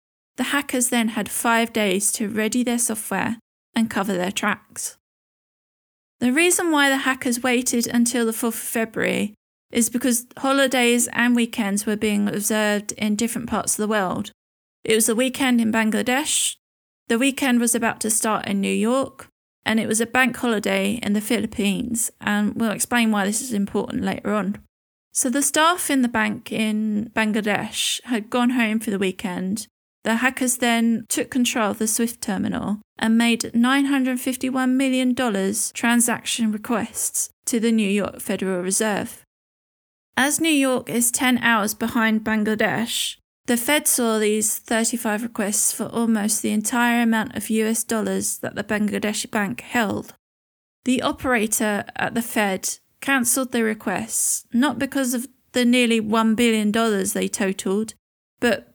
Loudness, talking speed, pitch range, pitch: -21 LUFS, 155 wpm, 215-245 Hz, 230 Hz